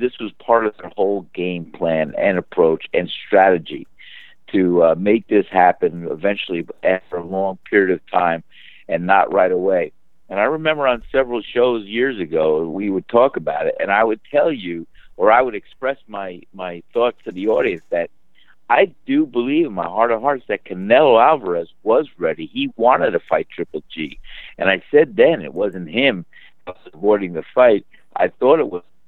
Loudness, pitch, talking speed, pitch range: -18 LUFS, 105 Hz, 185 wpm, 90-135 Hz